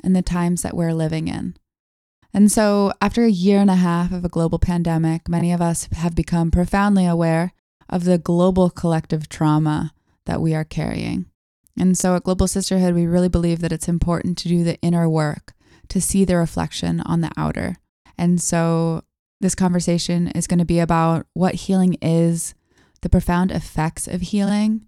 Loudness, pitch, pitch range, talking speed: -19 LUFS, 175 Hz, 165-185 Hz, 180 wpm